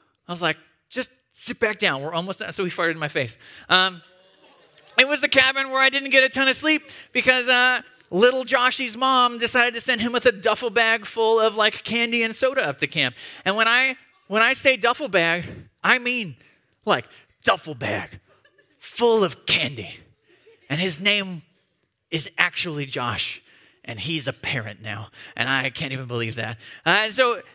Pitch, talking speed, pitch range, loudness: 215 Hz, 190 wpm, 160-250 Hz, -21 LUFS